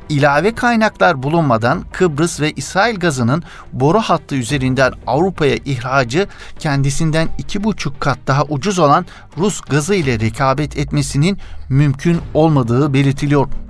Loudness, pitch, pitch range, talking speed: -16 LUFS, 145 Hz, 135-170 Hz, 120 wpm